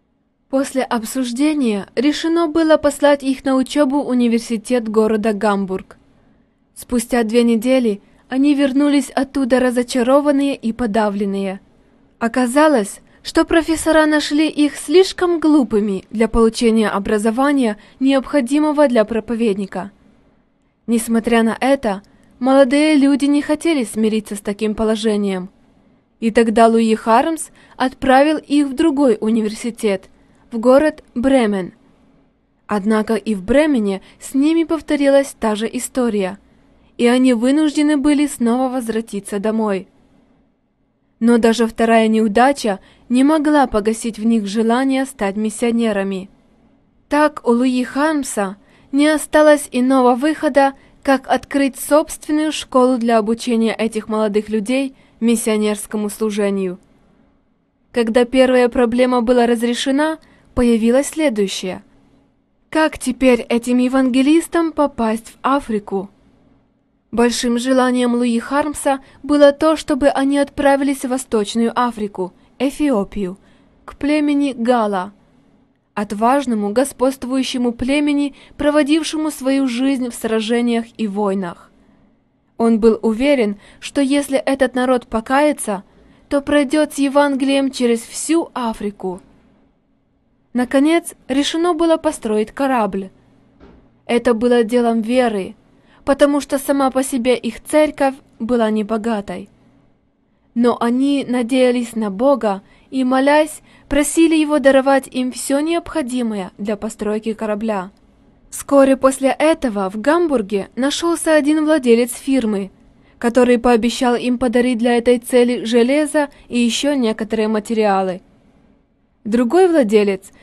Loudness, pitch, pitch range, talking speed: -16 LUFS, 250 Hz, 225-280 Hz, 110 wpm